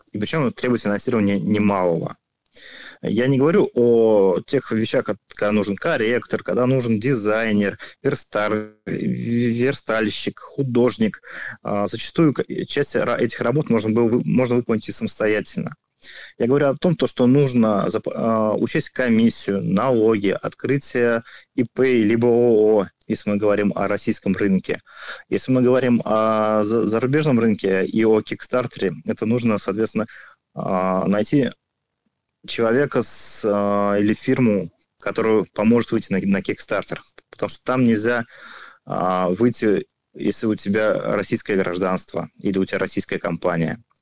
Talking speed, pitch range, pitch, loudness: 110 wpm, 105-125 Hz, 110 Hz, -20 LUFS